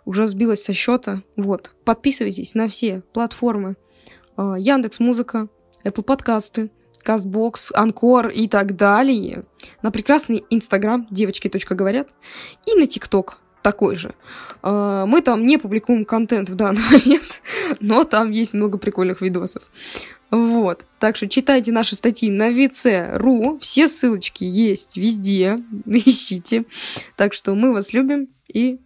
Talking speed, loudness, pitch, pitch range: 130 wpm, -18 LUFS, 225 Hz, 200-245 Hz